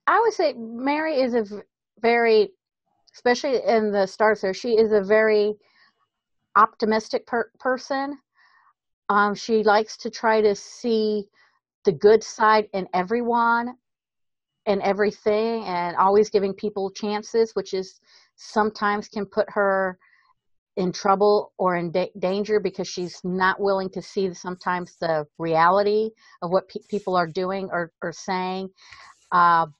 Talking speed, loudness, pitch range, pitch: 140 wpm, -23 LUFS, 185-225 Hz, 205 Hz